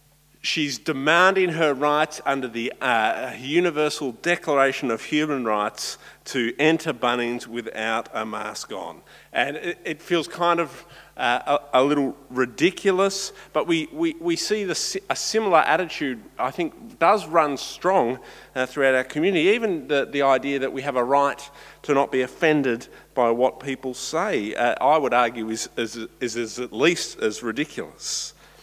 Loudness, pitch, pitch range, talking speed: -23 LUFS, 140 Hz, 125-165 Hz, 160 wpm